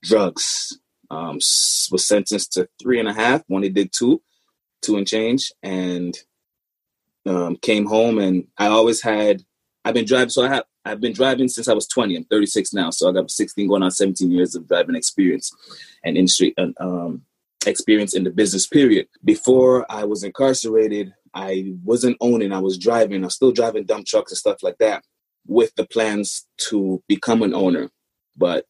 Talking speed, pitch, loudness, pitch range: 180 wpm, 105 Hz, -19 LUFS, 95-120 Hz